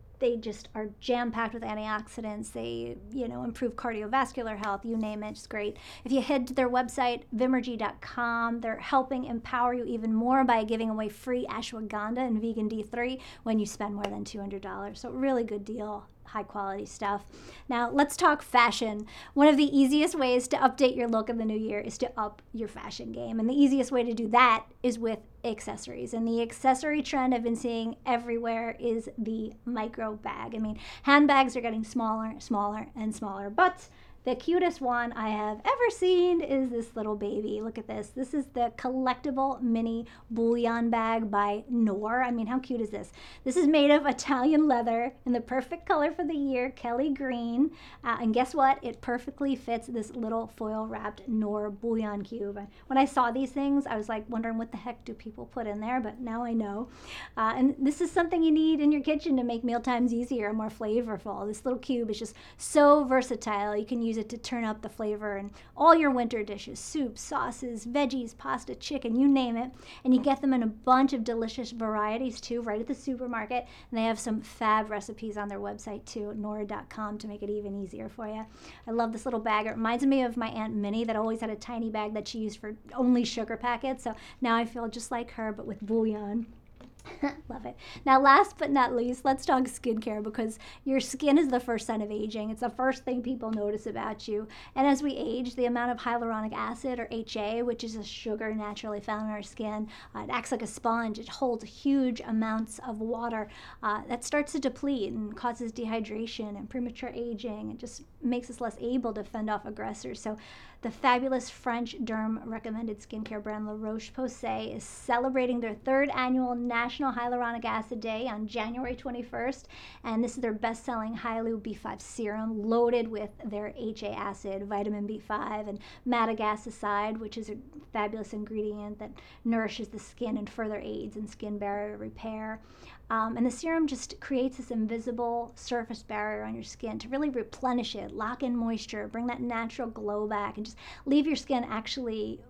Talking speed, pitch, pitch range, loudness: 200 wpm, 230 Hz, 215-255 Hz, -30 LUFS